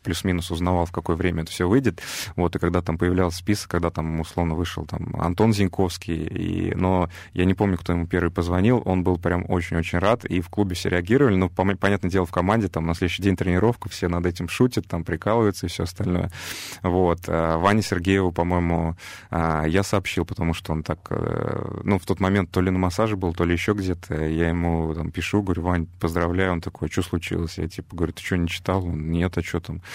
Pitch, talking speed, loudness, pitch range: 90 Hz, 215 wpm, -24 LUFS, 85-95 Hz